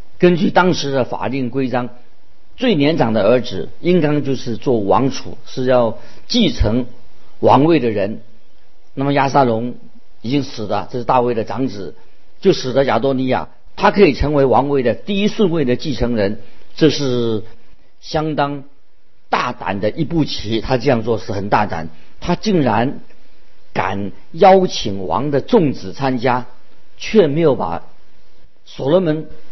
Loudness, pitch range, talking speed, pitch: -17 LUFS, 110-150 Hz, 215 characters per minute, 130 Hz